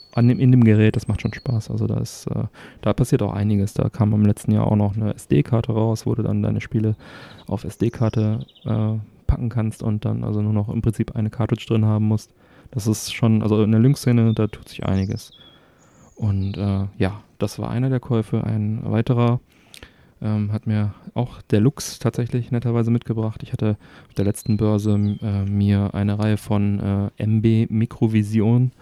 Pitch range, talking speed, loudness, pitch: 105-115 Hz, 195 wpm, -21 LUFS, 110 Hz